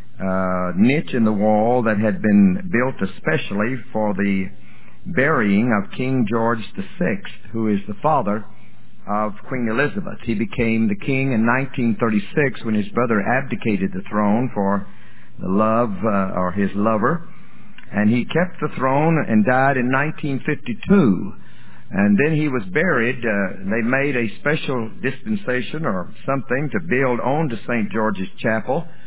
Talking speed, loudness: 150 wpm, -20 LUFS